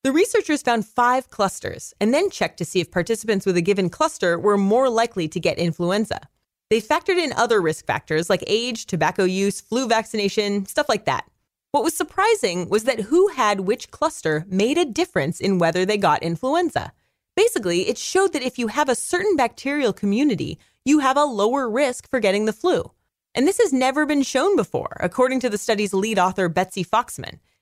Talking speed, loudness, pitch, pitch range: 195 wpm, -21 LUFS, 225 Hz, 190-295 Hz